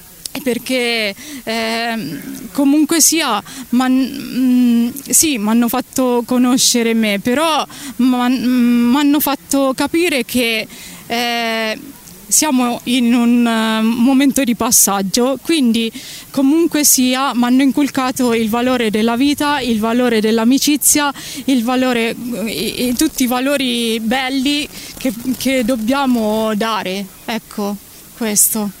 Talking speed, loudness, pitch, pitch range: 110 wpm, -15 LUFS, 250 Hz, 230-270 Hz